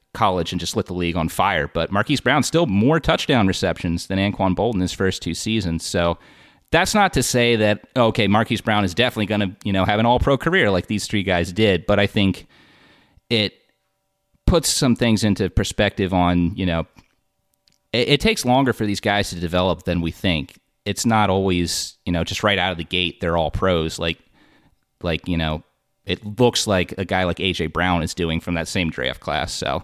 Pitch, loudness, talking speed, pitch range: 95 Hz, -20 LUFS, 210 wpm, 85-110 Hz